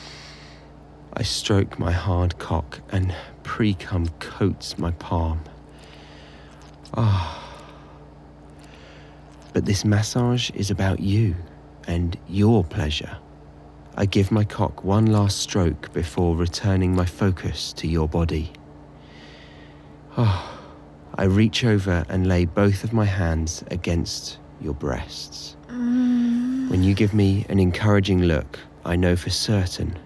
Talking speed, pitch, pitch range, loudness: 120 wpm, 90 Hz, 75-100 Hz, -23 LUFS